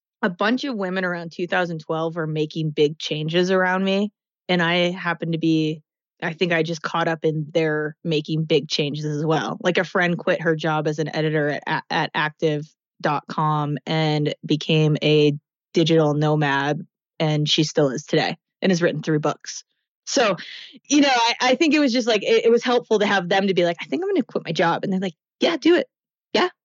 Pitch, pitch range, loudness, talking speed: 165 Hz, 155-190 Hz, -21 LUFS, 205 wpm